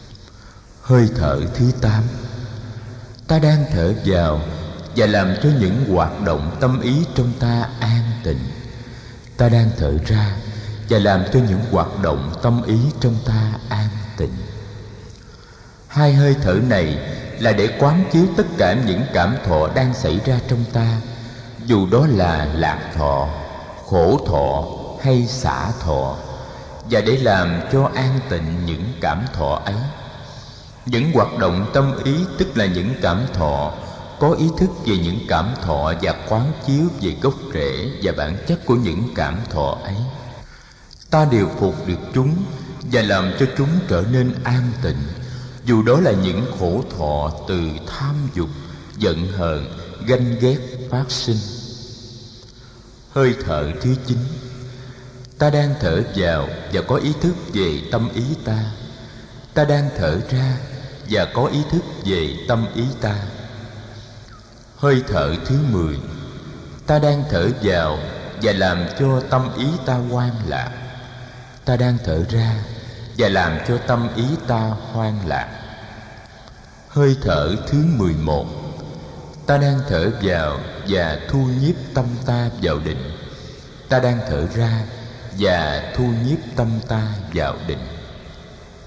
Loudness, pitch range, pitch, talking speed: -19 LUFS, 95-130 Hz, 115 Hz, 145 wpm